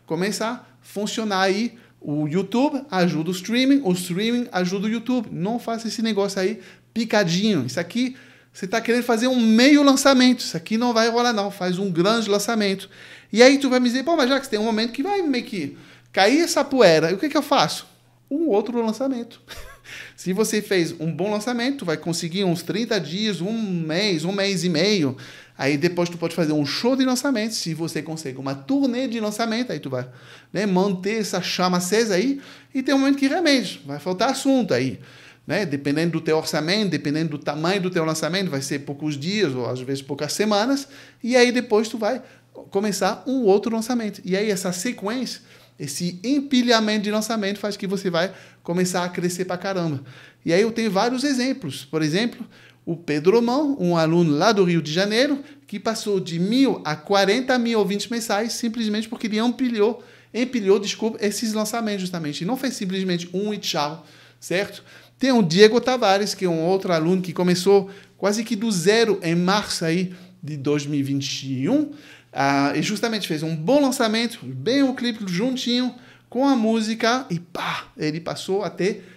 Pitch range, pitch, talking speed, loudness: 175-235 Hz, 205 Hz, 190 wpm, -22 LUFS